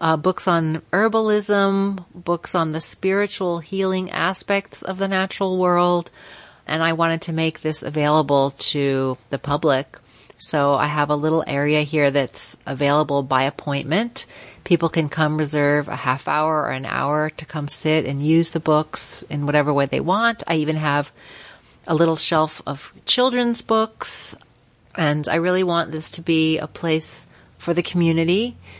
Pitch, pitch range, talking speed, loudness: 160 Hz, 145-175 Hz, 165 wpm, -20 LUFS